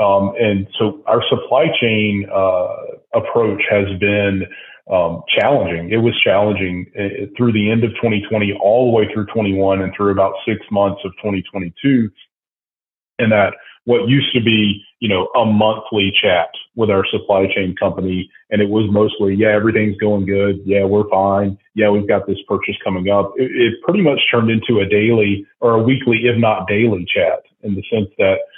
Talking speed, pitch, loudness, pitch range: 185 wpm, 105 Hz, -16 LUFS, 100-115 Hz